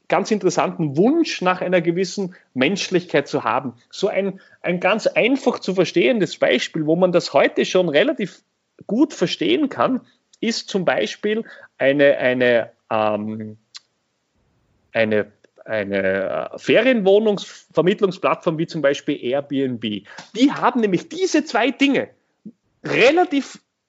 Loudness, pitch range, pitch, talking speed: -19 LUFS, 140-230 Hz, 185 Hz, 115 wpm